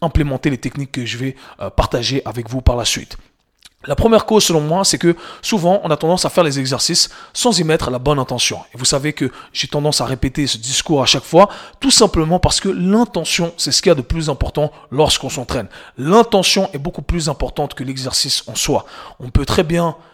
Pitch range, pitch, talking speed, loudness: 135-175 Hz, 150 Hz, 220 wpm, -16 LUFS